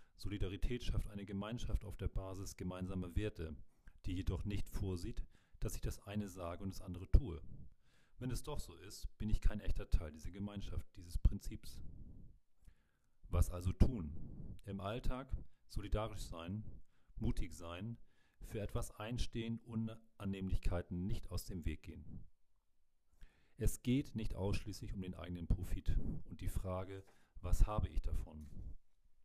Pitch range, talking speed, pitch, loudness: 85-105 Hz, 145 wpm, 95 Hz, -44 LUFS